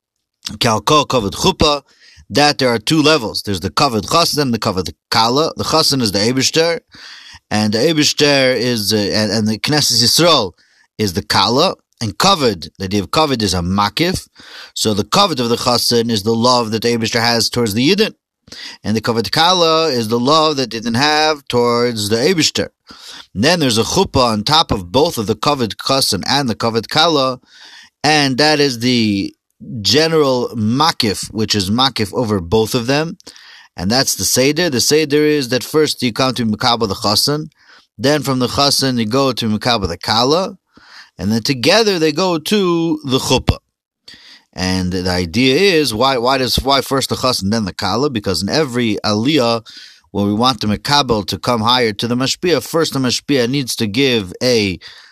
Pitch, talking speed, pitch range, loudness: 120 Hz, 185 wpm, 110-145 Hz, -14 LUFS